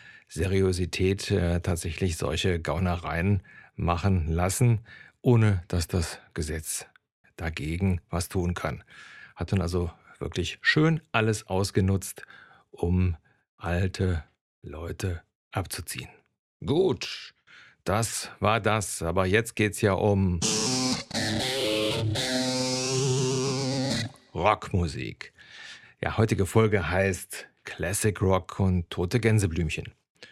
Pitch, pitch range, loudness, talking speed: 95 Hz, 90-110 Hz, -27 LUFS, 90 wpm